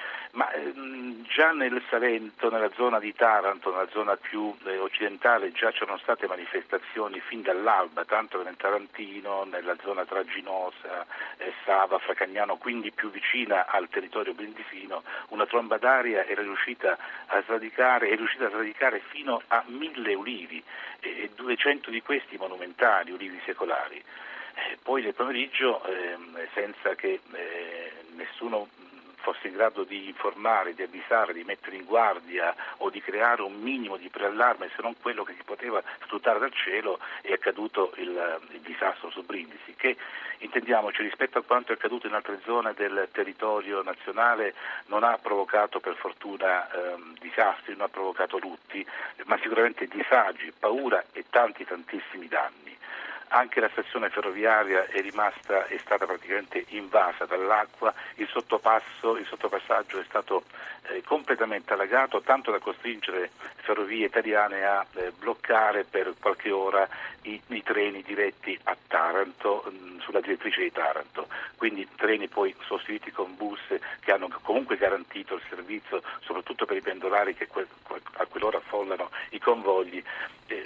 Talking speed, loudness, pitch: 145 wpm, -28 LUFS, 120 Hz